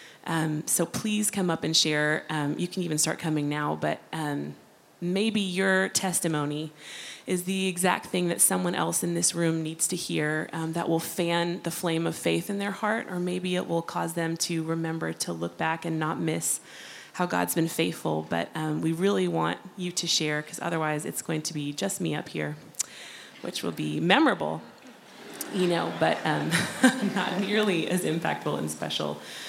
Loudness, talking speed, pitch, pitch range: -27 LUFS, 190 wpm, 165 Hz, 150-180 Hz